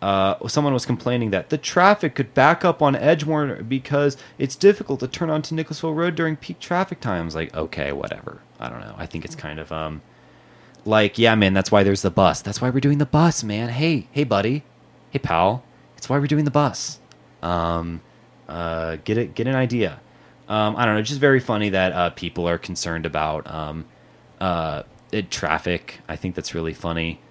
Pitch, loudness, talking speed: 110 Hz, -21 LUFS, 200 wpm